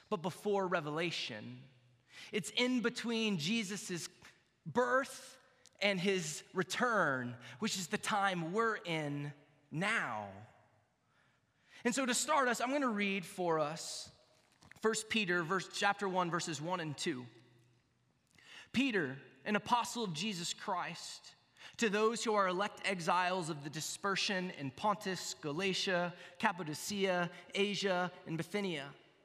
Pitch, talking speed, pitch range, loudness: 185 Hz, 125 wpm, 155-210 Hz, -36 LUFS